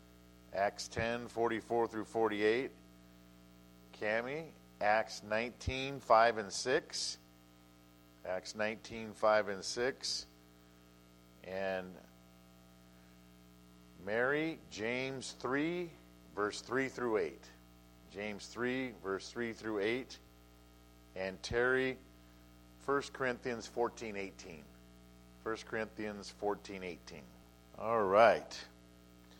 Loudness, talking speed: -36 LUFS, 85 wpm